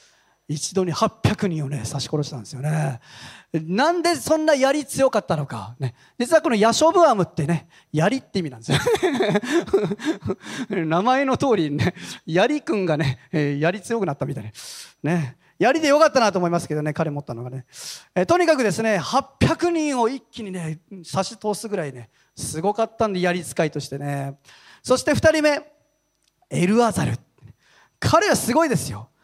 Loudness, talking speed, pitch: -21 LUFS, 310 characters per minute, 185 Hz